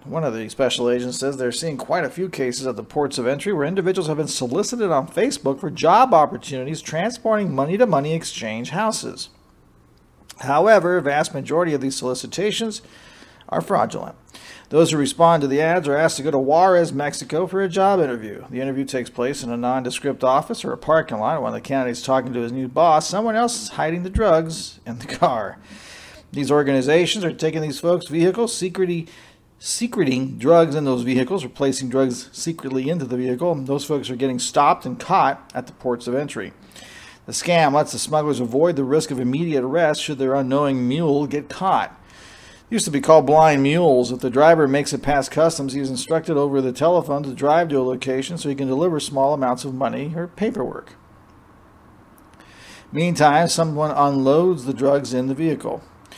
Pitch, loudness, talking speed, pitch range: 145 Hz, -20 LUFS, 190 wpm, 130-165 Hz